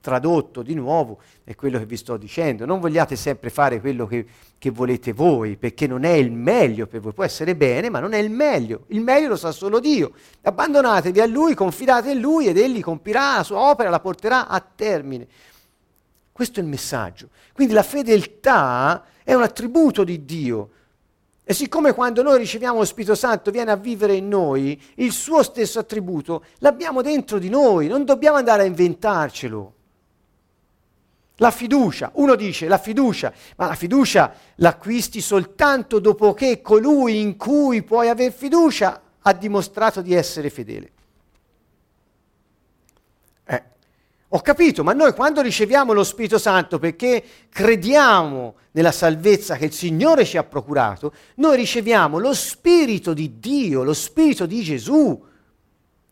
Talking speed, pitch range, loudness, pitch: 155 wpm, 150-250 Hz, -19 LUFS, 200 Hz